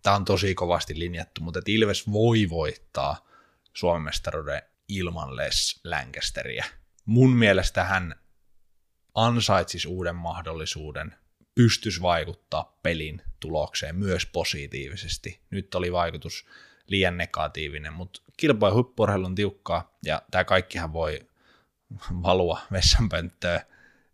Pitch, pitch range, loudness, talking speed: 90 Hz, 85-100 Hz, -26 LUFS, 105 wpm